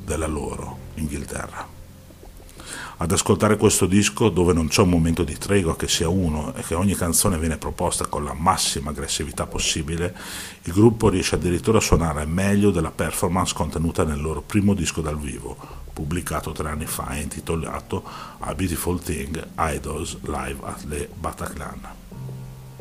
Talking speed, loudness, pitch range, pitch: 155 wpm, -23 LUFS, 75-95 Hz, 85 Hz